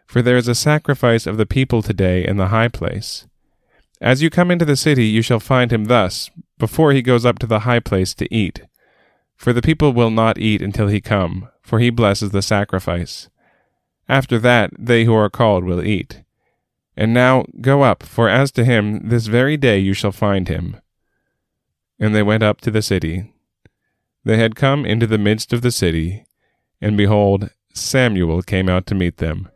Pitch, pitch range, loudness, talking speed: 110 Hz, 100-125 Hz, -16 LUFS, 195 wpm